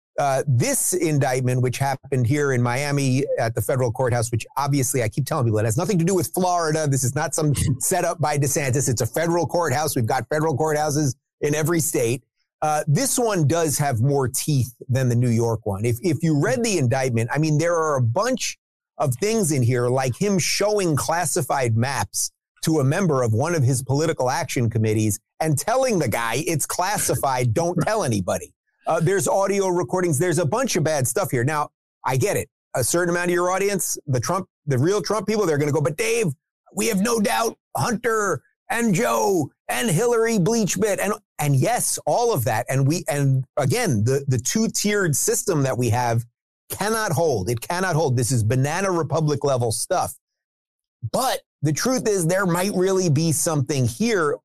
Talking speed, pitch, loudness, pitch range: 195 wpm, 150 Hz, -21 LUFS, 130-180 Hz